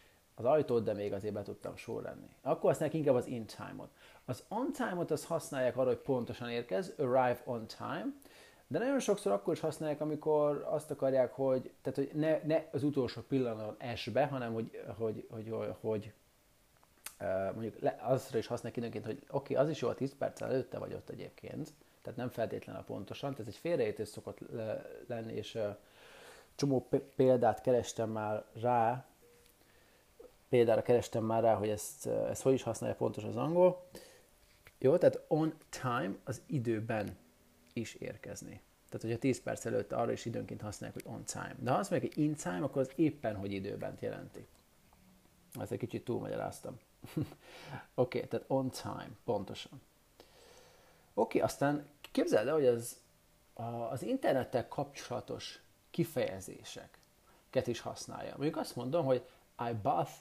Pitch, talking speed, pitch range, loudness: 125 Hz, 160 wpm, 115-150 Hz, -36 LUFS